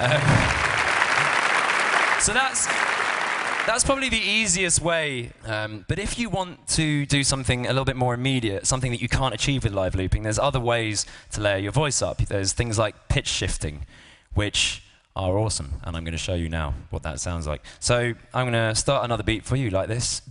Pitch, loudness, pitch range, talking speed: 115 Hz, -23 LUFS, 95-135 Hz, 200 wpm